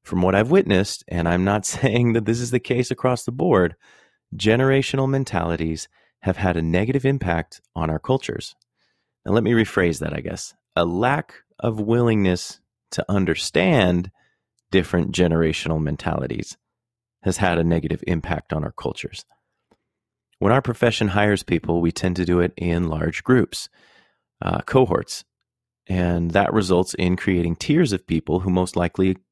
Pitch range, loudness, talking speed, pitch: 85-120 Hz, -21 LUFS, 155 wpm, 95 Hz